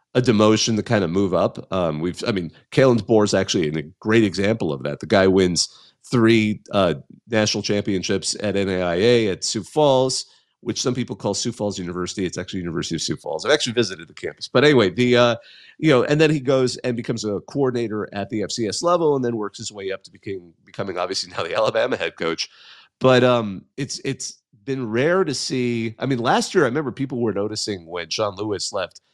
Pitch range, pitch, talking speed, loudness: 100-125 Hz, 110 Hz, 215 wpm, -21 LUFS